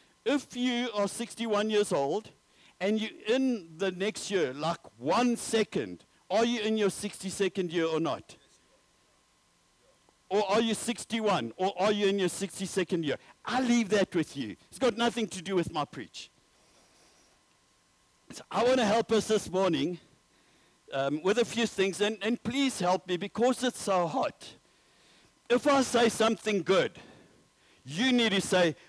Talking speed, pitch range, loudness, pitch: 160 wpm, 185-230 Hz, -29 LUFS, 205 Hz